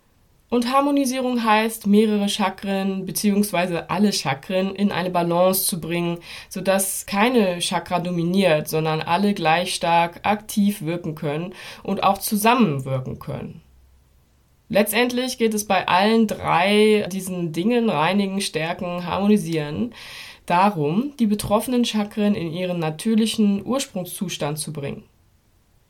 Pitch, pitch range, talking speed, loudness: 190 Hz, 170-210 Hz, 115 wpm, -21 LUFS